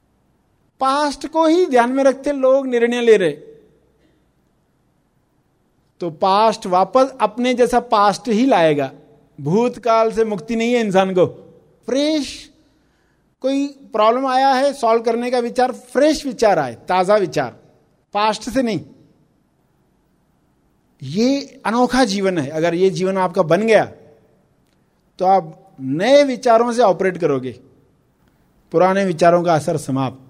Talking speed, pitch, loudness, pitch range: 125 wpm, 220 Hz, -17 LUFS, 175-255 Hz